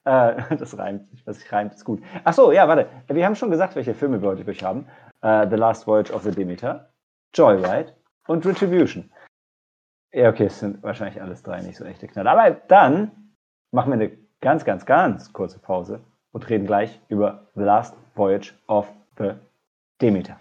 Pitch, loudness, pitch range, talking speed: 110 Hz, -20 LUFS, 105-150 Hz, 180 wpm